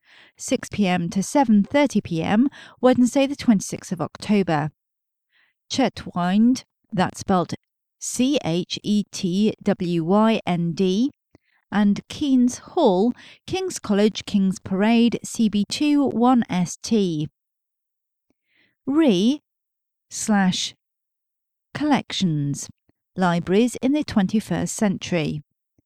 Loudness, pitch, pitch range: -22 LUFS, 205 Hz, 185-245 Hz